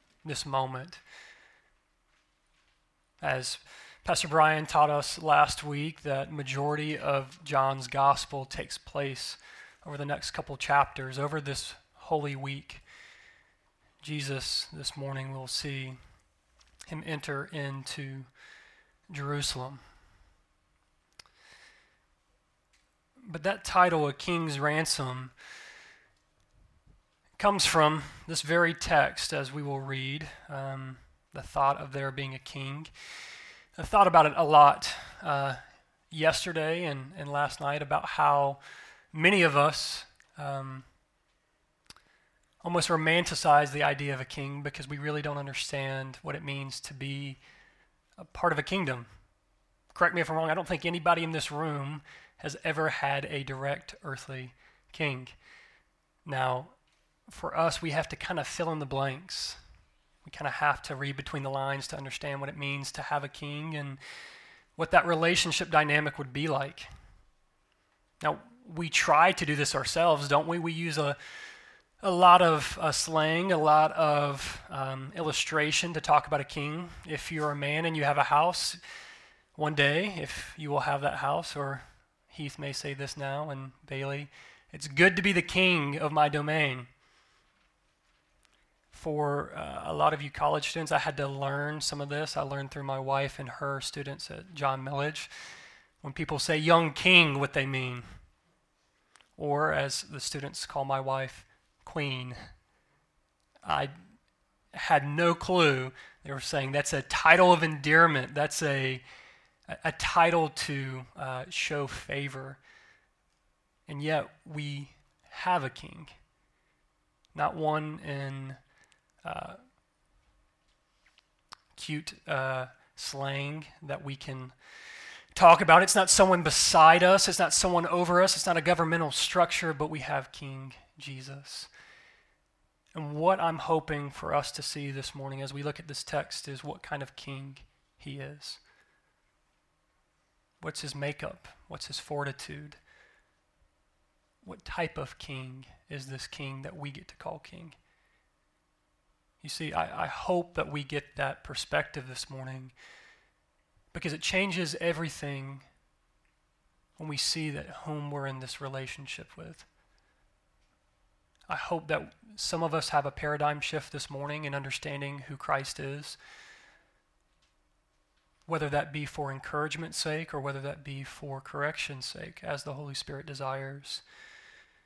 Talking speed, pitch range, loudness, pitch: 145 wpm, 135-160 Hz, -29 LUFS, 145 Hz